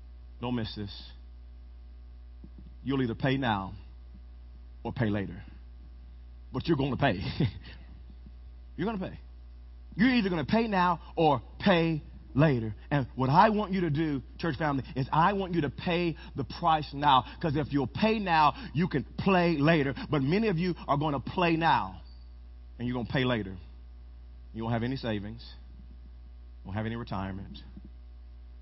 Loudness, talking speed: -29 LUFS, 170 wpm